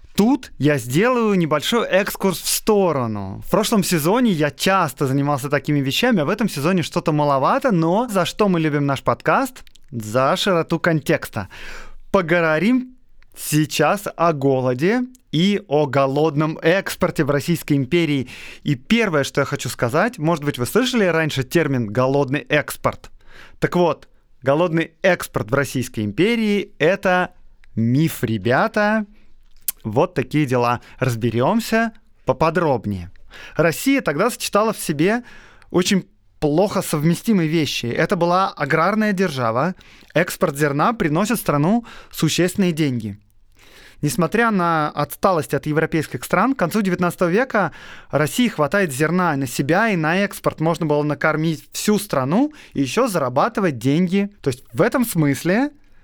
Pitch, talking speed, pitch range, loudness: 165 Hz, 130 wpm, 140-195 Hz, -19 LUFS